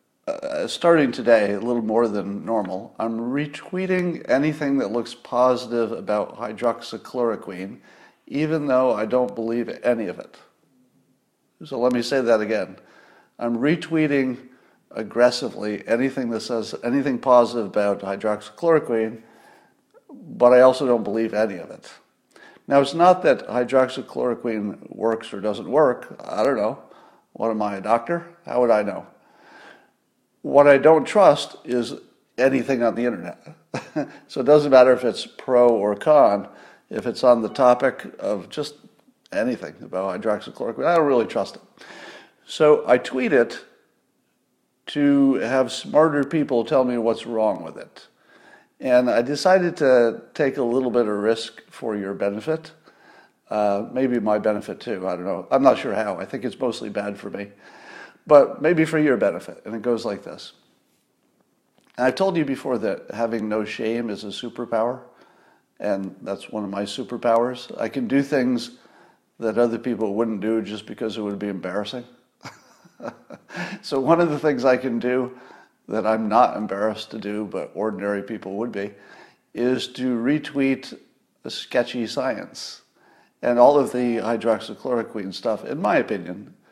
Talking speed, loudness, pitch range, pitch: 155 wpm, -22 LUFS, 110-135 Hz, 120 Hz